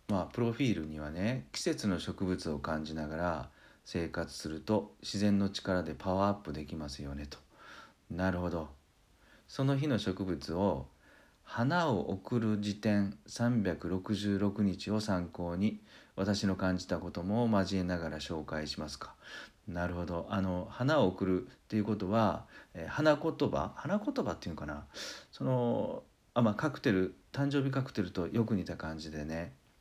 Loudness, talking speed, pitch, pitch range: -34 LUFS, 285 characters per minute, 95 Hz, 85-105 Hz